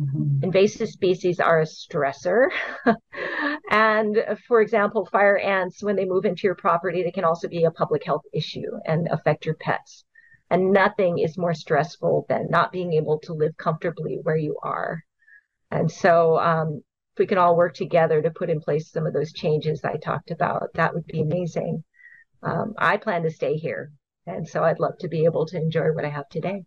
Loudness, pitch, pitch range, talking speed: -23 LUFS, 170 Hz, 160-195 Hz, 195 wpm